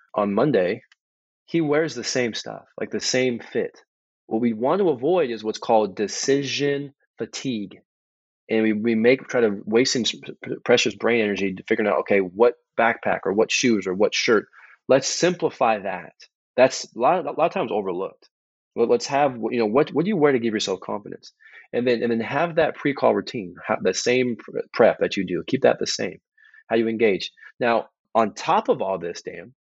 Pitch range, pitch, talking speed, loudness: 110-145 Hz, 120 Hz, 200 wpm, -22 LUFS